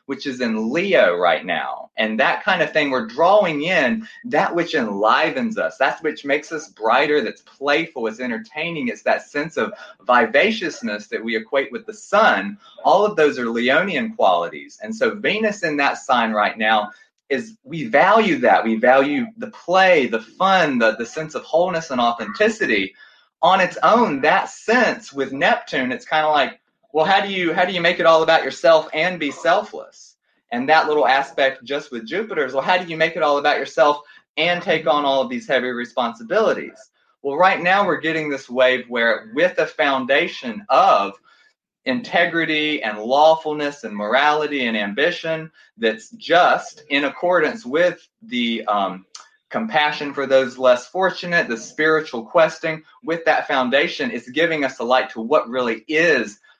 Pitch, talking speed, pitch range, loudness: 155 Hz, 175 wpm, 135-185 Hz, -19 LUFS